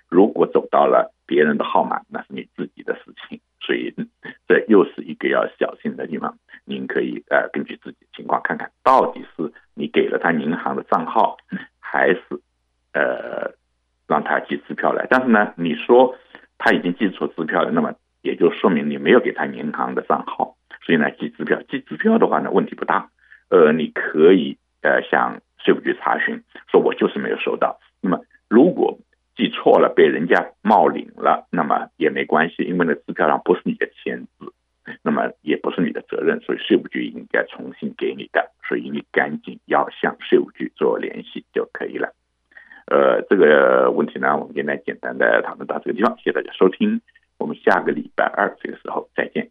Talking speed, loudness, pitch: 285 characters per minute, -19 LUFS, 375 Hz